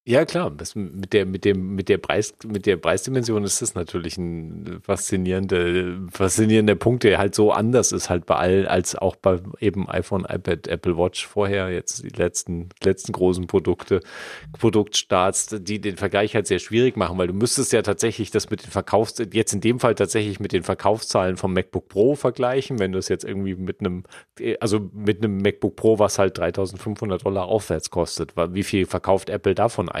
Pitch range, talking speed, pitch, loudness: 95-110 Hz, 195 wpm, 100 Hz, -22 LUFS